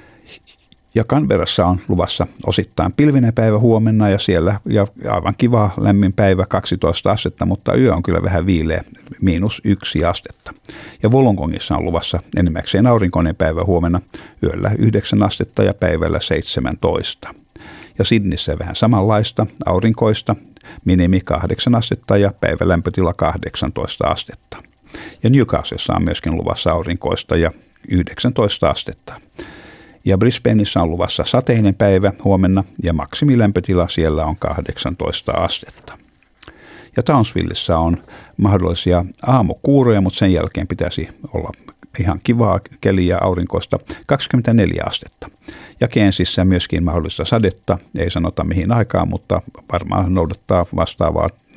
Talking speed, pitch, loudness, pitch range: 120 wpm, 95 Hz, -17 LUFS, 90-110 Hz